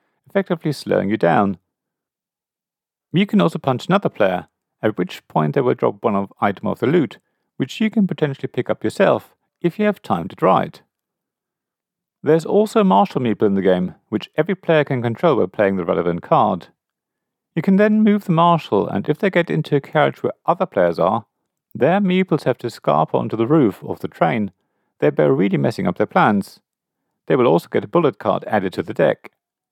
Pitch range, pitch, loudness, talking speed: 115-190 Hz, 155 Hz, -19 LUFS, 200 wpm